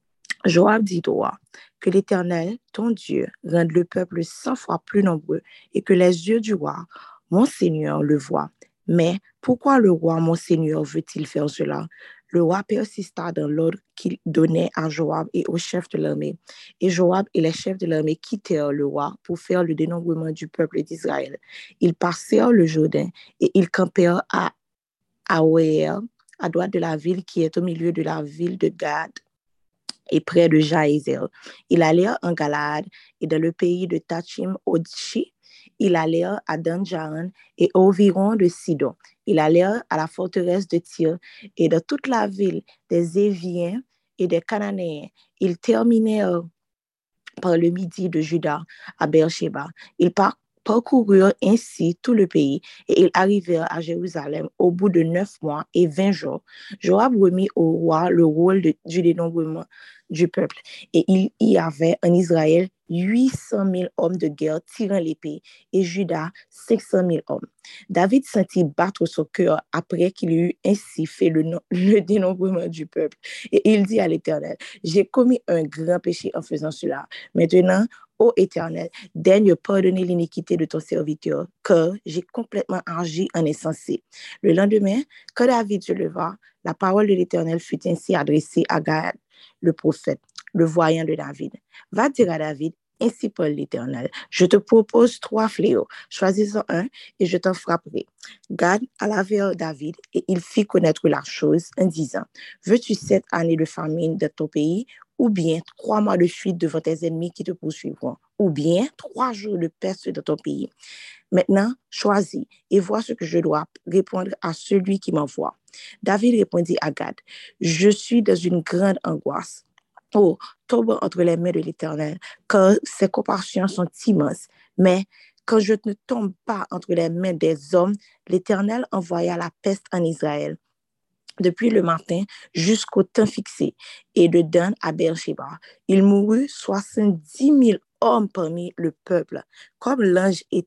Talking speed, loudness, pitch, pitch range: 165 wpm, -21 LUFS, 180 Hz, 165-200 Hz